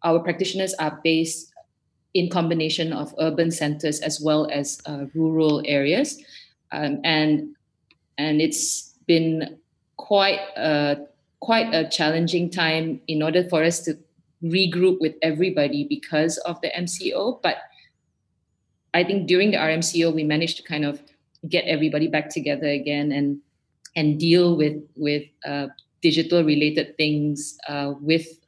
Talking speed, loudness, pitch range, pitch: 135 wpm, -22 LUFS, 150-170 Hz, 155 Hz